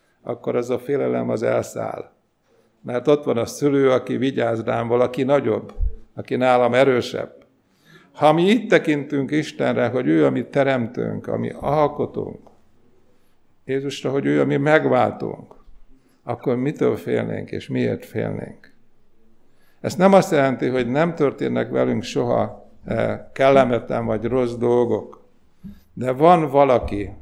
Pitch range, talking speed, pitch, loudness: 120-145 Hz, 130 wpm, 130 Hz, -20 LUFS